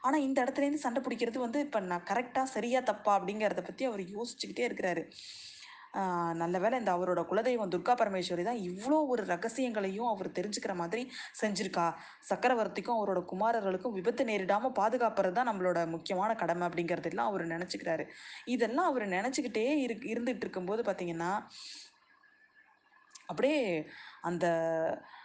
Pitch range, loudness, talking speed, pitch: 180-250 Hz, -33 LUFS, 125 wpm, 215 Hz